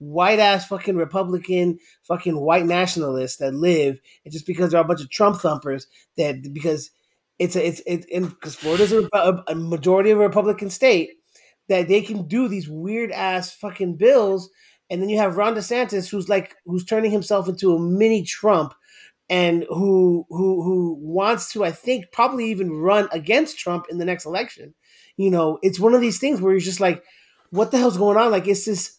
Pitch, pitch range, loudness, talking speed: 190 Hz, 170-210 Hz, -20 LUFS, 195 wpm